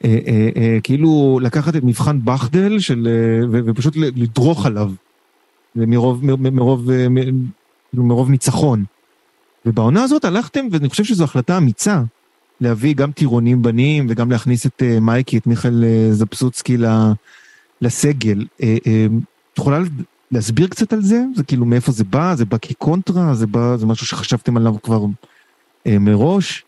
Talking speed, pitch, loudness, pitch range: 115 wpm, 125 Hz, -16 LUFS, 115-150 Hz